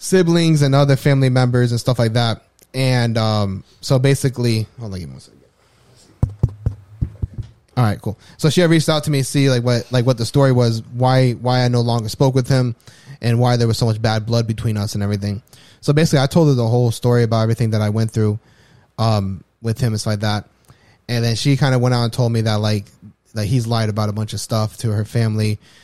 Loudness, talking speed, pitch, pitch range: -18 LUFS, 235 wpm, 115 Hz, 110-130 Hz